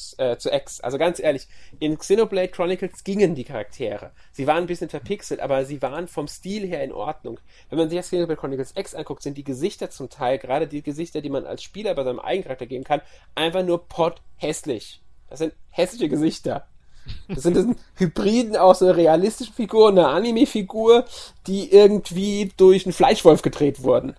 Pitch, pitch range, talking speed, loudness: 175 Hz, 150-195 Hz, 180 wpm, -21 LUFS